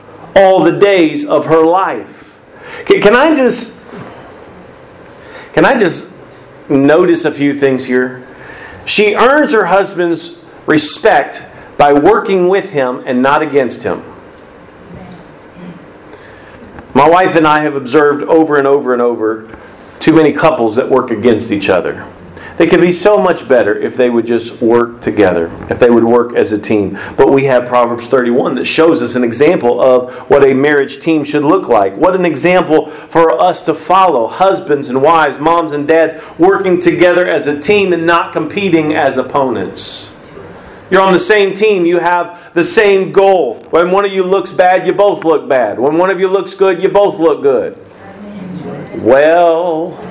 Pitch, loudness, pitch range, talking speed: 165 Hz, -10 LUFS, 140-190 Hz, 170 wpm